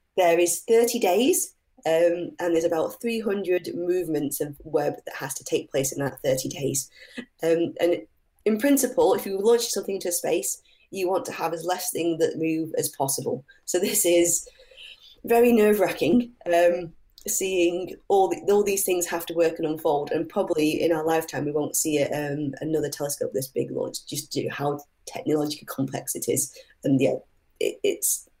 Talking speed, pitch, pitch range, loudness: 190 wpm, 175 Hz, 160-210 Hz, -24 LUFS